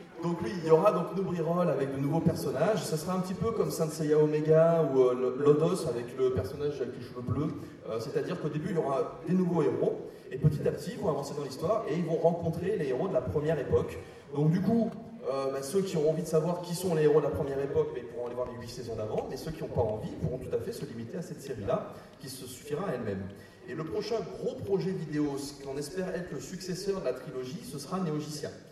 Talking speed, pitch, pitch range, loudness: 260 wpm, 160 Hz, 140-180 Hz, -31 LUFS